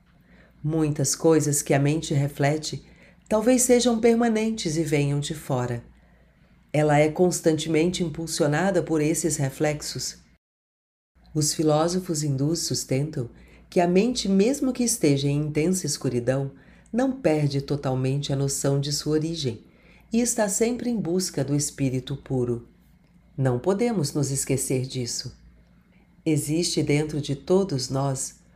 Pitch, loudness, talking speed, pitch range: 150 Hz, -24 LUFS, 125 wpm, 140-175 Hz